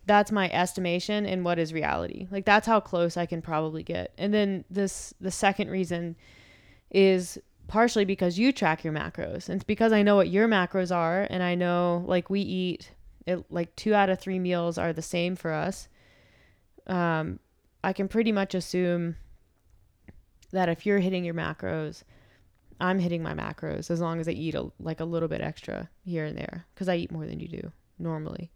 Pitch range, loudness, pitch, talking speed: 165-195 Hz, -28 LUFS, 175 Hz, 195 wpm